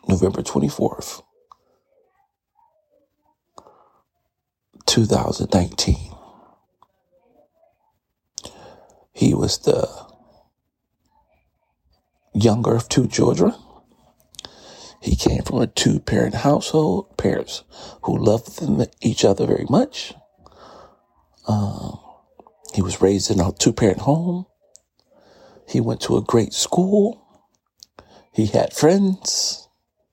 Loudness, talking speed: -20 LUFS, 85 wpm